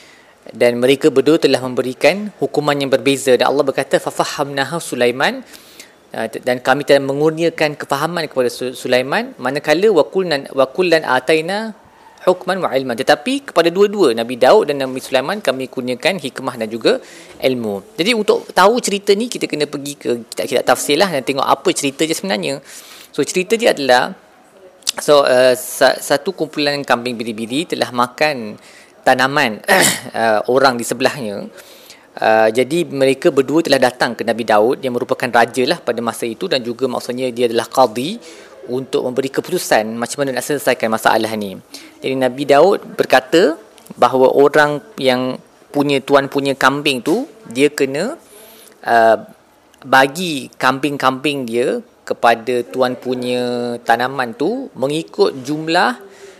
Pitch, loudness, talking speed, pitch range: 135 Hz, -16 LUFS, 140 wpm, 125-155 Hz